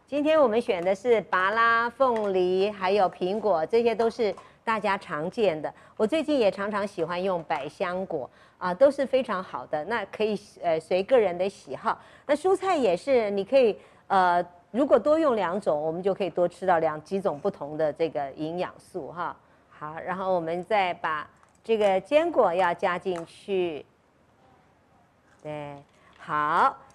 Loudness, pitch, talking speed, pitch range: -26 LUFS, 190 Hz, 235 characters per minute, 175-230 Hz